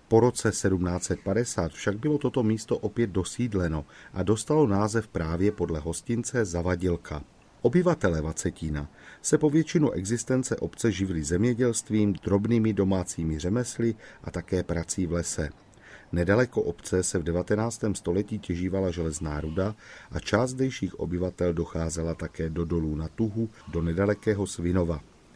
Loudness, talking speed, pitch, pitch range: -28 LUFS, 130 wpm, 95 Hz, 85-115 Hz